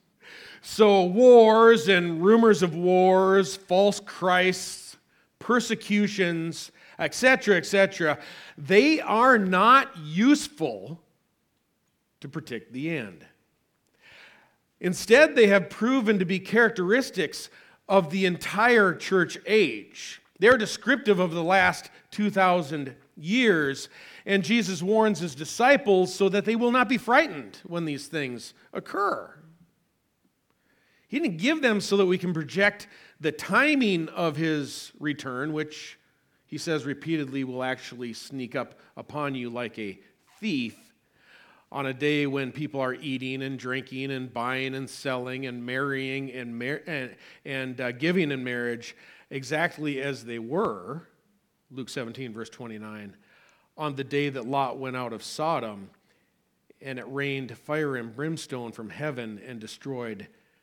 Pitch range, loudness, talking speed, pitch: 135-195 Hz, -24 LUFS, 130 wpm, 160 Hz